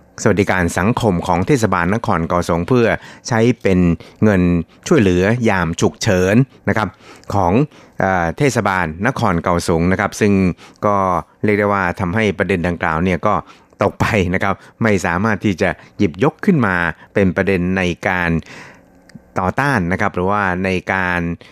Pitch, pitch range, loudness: 95 Hz, 90-105 Hz, -17 LUFS